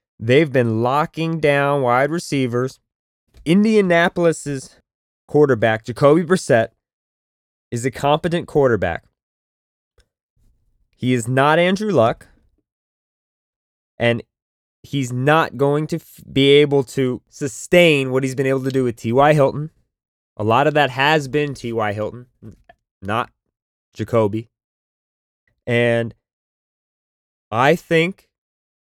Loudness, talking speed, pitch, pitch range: -18 LUFS, 105 wpm, 130 Hz, 115-150 Hz